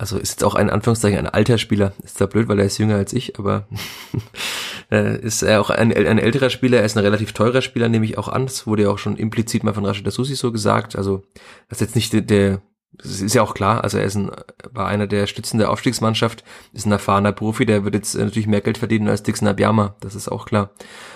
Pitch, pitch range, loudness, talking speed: 105 Hz, 100-115 Hz, -19 LUFS, 250 wpm